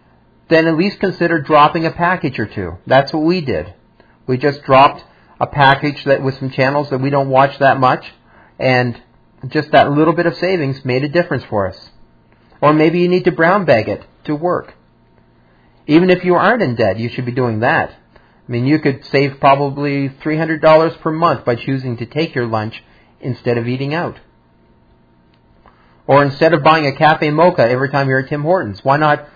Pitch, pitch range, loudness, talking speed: 140 Hz, 125-160 Hz, -14 LUFS, 200 wpm